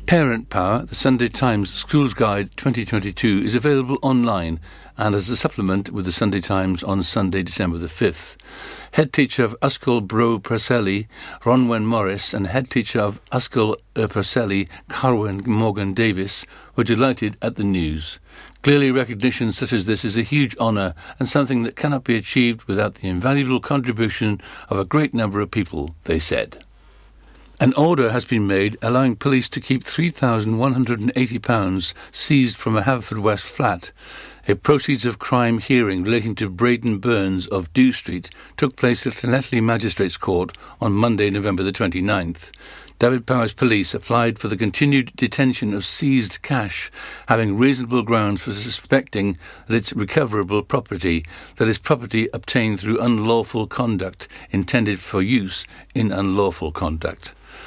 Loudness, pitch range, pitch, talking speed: -20 LUFS, 100-125 Hz, 115 Hz, 150 wpm